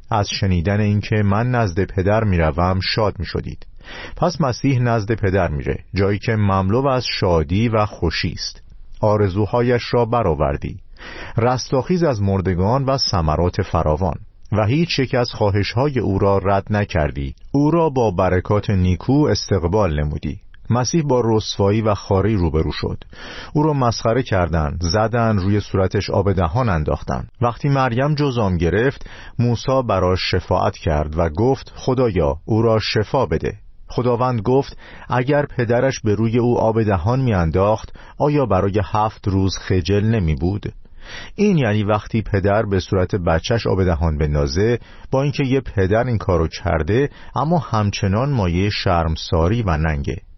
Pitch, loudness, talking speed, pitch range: 105 Hz, -19 LUFS, 145 wpm, 90-120 Hz